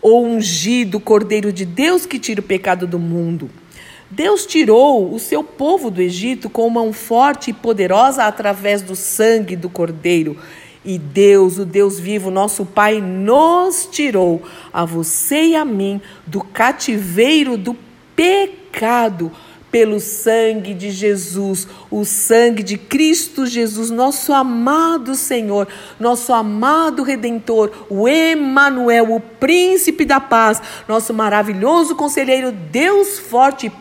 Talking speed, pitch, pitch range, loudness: 130 wpm, 225 Hz, 200-270 Hz, -15 LUFS